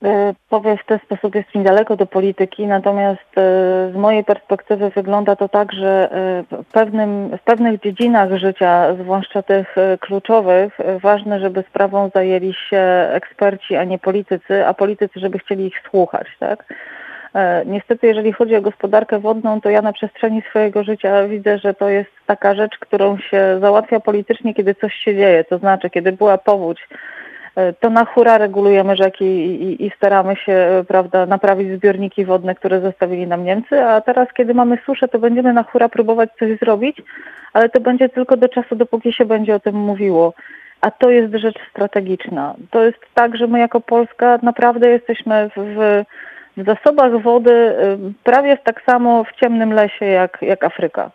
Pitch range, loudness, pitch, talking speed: 195-230 Hz, -15 LUFS, 205 Hz, 165 wpm